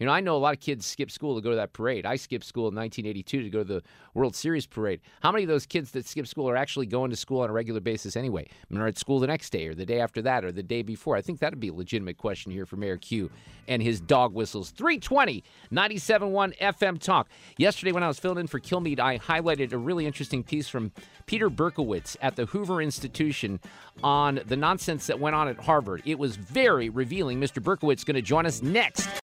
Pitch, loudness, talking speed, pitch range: 135 Hz, -28 LUFS, 250 wpm, 115-160 Hz